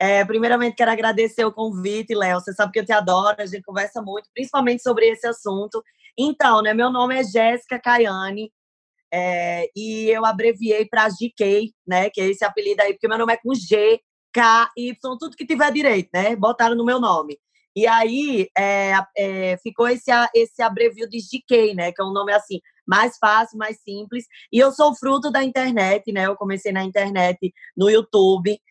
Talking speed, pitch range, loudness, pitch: 190 wpm, 200-240 Hz, -19 LUFS, 220 Hz